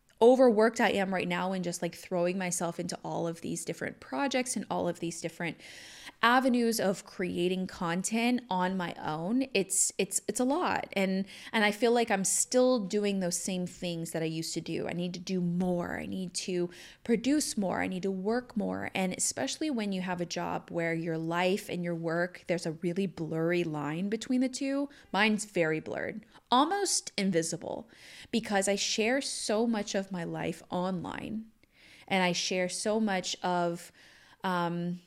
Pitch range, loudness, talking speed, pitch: 175-225 Hz, -31 LUFS, 180 wpm, 190 Hz